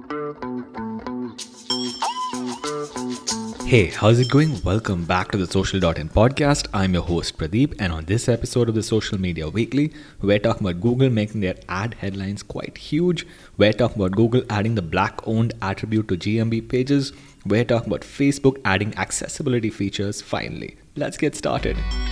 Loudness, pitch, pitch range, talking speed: -22 LUFS, 110 Hz, 100-125 Hz, 150 wpm